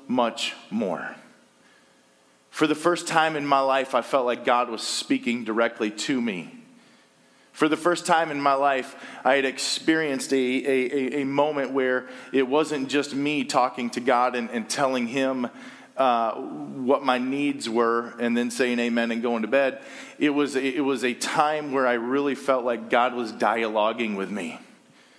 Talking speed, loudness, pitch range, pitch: 175 wpm, -24 LUFS, 120-145 Hz, 135 Hz